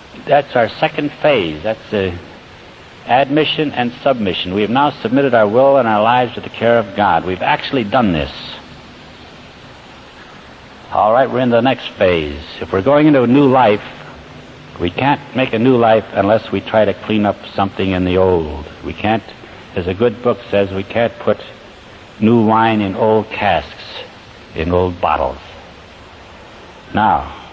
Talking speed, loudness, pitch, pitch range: 165 wpm, -15 LUFS, 110 Hz, 95-120 Hz